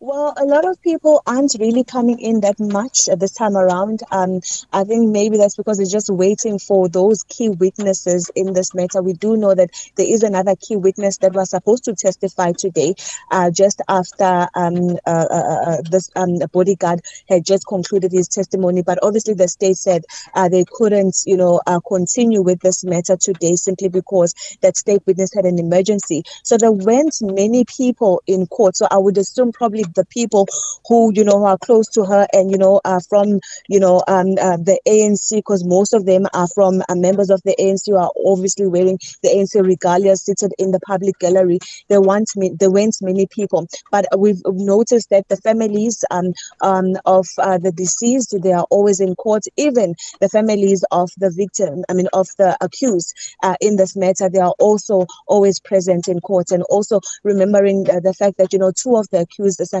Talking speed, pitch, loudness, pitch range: 200 wpm, 195 Hz, -16 LUFS, 185-205 Hz